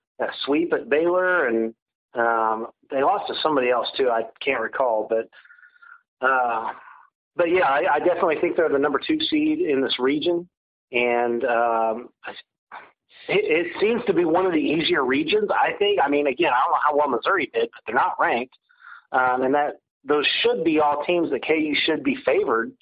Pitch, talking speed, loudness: 175 Hz, 185 wpm, -22 LUFS